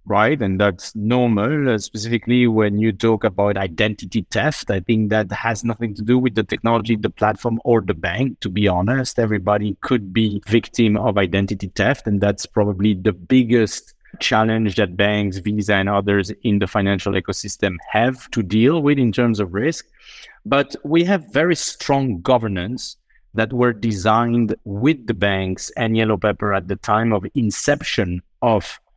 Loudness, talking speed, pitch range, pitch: -19 LUFS, 170 wpm, 100-120 Hz, 110 Hz